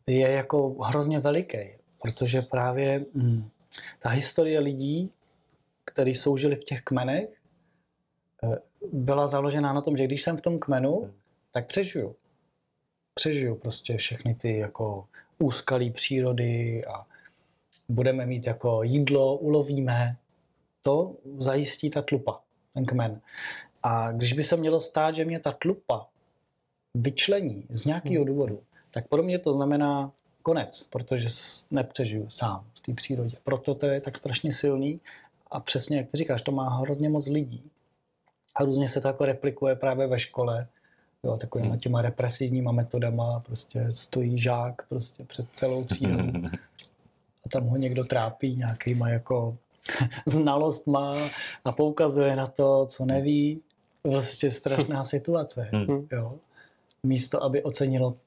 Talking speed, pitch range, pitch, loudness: 135 wpm, 120-145 Hz, 135 Hz, -27 LUFS